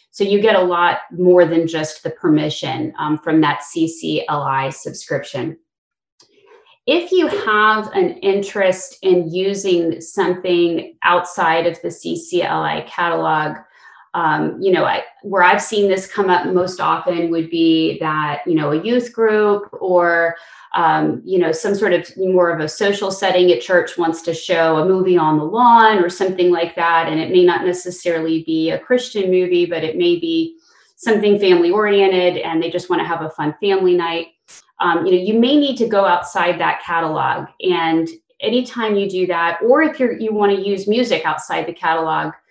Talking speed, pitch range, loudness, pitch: 180 wpm, 165-210 Hz, -17 LUFS, 180 Hz